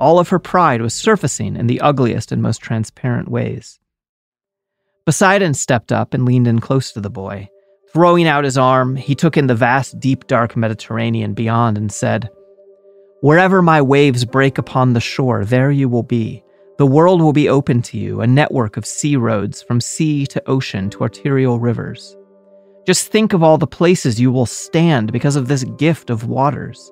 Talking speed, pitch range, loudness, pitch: 185 wpm, 120-170 Hz, -15 LUFS, 135 Hz